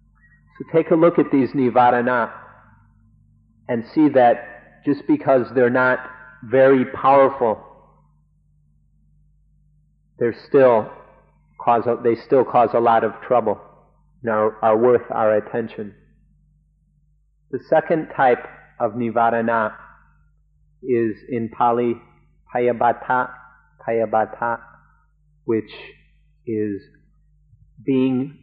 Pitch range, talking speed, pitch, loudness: 110-135 Hz, 95 wpm, 120 Hz, -19 LUFS